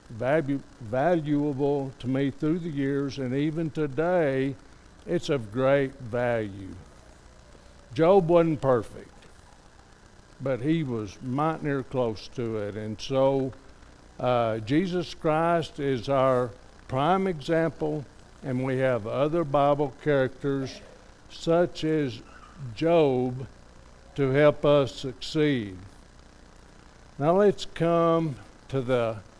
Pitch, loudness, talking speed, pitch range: 135 Hz, -26 LUFS, 105 wpm, 115-155 Hz